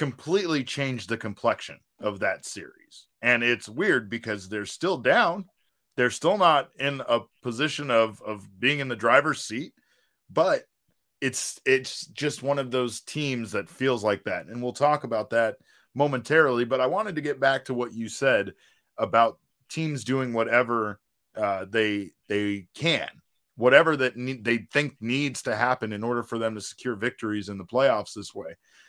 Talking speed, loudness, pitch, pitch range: 170 wpm, -26 LUFS, 120 Hz, 115-135 Hz